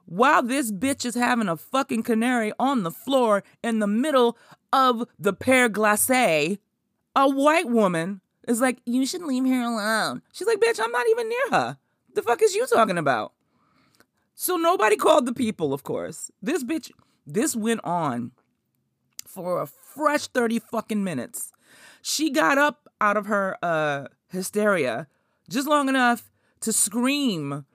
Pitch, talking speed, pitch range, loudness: 245 Hz, 160 wpm, 210-275 Hz, -23 LUFS